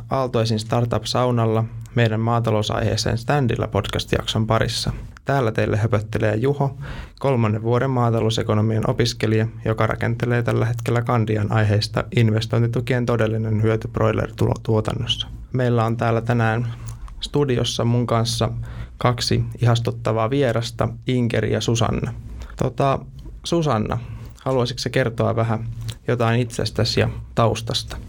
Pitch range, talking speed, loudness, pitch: 110-120 Hz, 105 wpm, -21 LUFS, 115 Hz